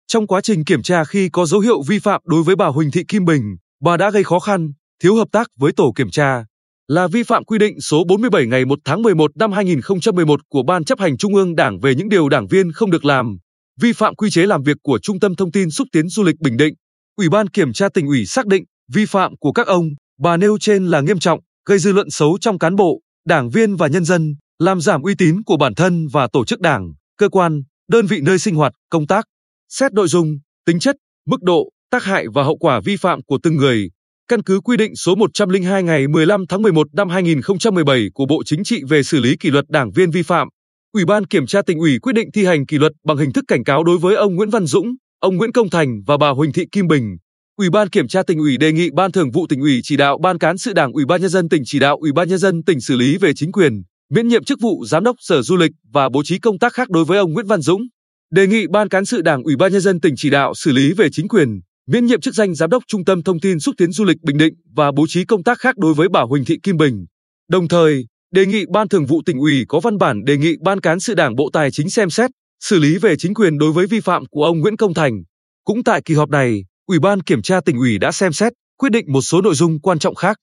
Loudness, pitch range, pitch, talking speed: -15 LUFS, 150-205 Hz, 175 Hz, 270 wpm